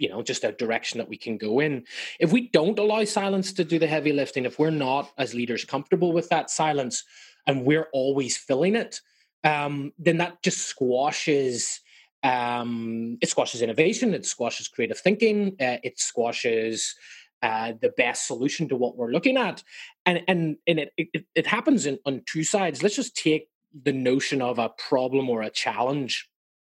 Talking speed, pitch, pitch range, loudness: 185 wpm, 145 Hz, 125-175 Hz, -25 LUFS